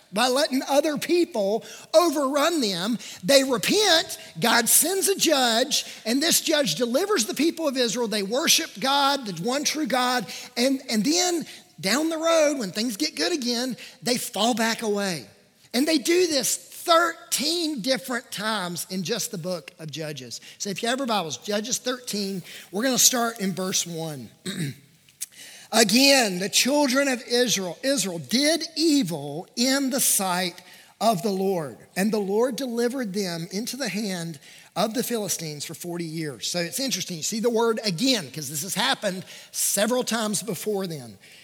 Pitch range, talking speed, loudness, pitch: 190-270 Hz, 165 wpm, -23 LUFS, 235 Hz